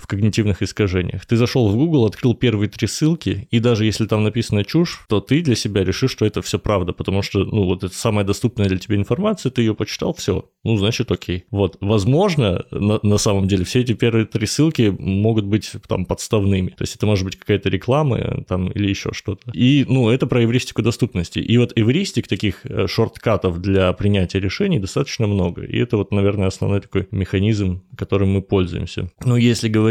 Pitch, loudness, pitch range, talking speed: 105 Hz, -19 LUFS, 100-120 Hz, 195 wpm